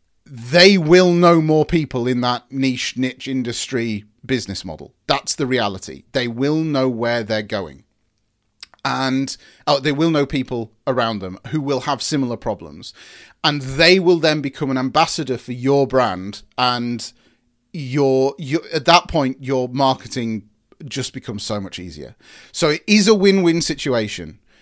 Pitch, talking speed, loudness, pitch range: 130 Hz, 155 wpm, -18 LUFS, 120-150 Hz